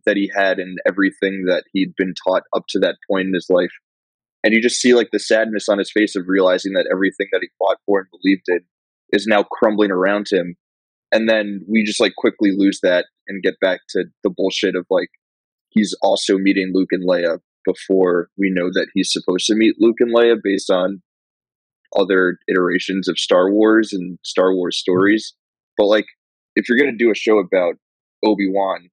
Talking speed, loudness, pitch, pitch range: 205 wpm, -17 LUFS, 95 Hz, 95-105 Hz